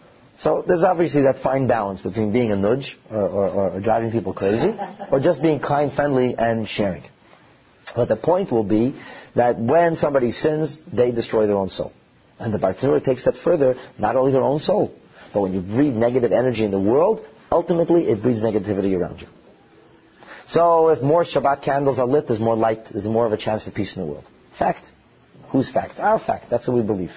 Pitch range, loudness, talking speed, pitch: 110-145 Hz, -20 LUFS, 205 wpm, 120 Hz